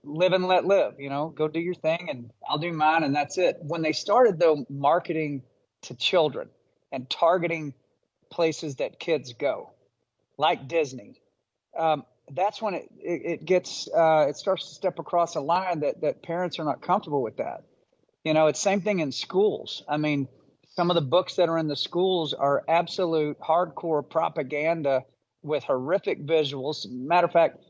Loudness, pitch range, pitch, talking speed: -26 LUFS, 150-180 Hz, 165 Hz, 180 wpm